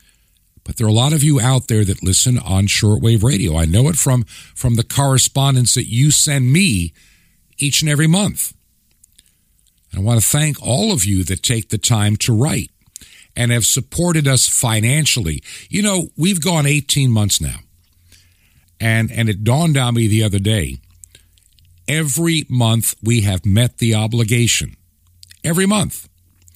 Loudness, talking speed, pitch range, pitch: -15 LUFS, 165 wpm, 95-135 Hz, 115 Hz